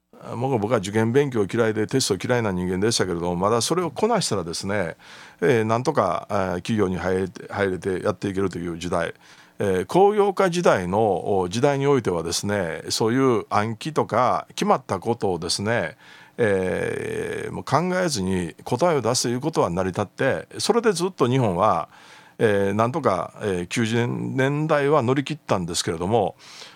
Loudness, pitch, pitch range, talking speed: -23 LUFS, 115 Hz, 95-150 Hz, 335 characters per minute